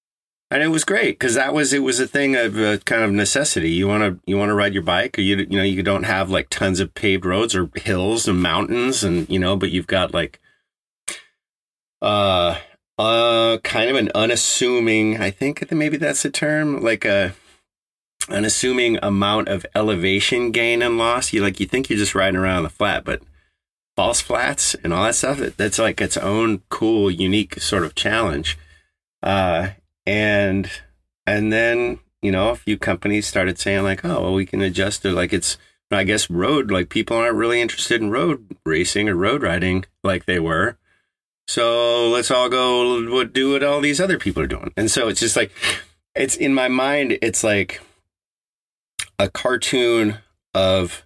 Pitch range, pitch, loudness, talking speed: 95-120 Hz, 105 Hz, -19 LUFS, 190 wpm